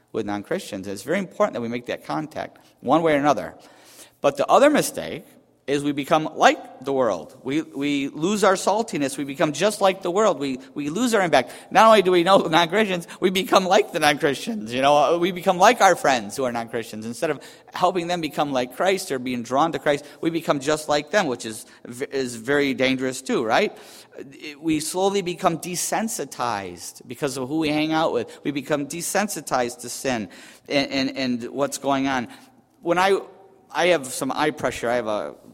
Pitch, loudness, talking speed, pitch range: 150 Hz, -22 LUFS, 200 wpm, 130-180 Hz